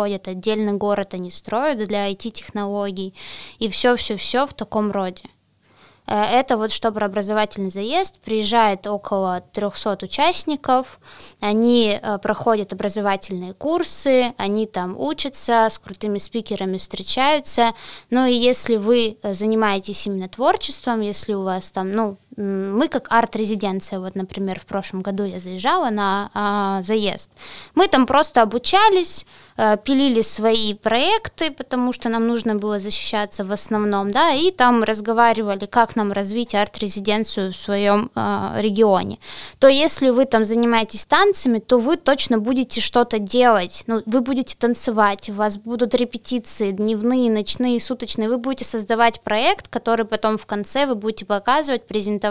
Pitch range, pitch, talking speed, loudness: 205-245 Hz, 220 Hz, 140 wpm, -19 LUFS